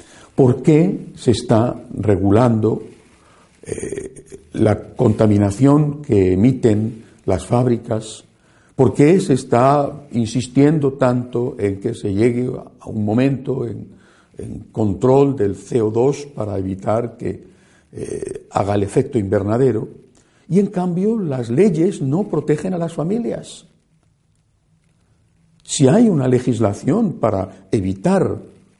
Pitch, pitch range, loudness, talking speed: 125 Hz, 110-145 Hz, -18 LUFS, 115 wpm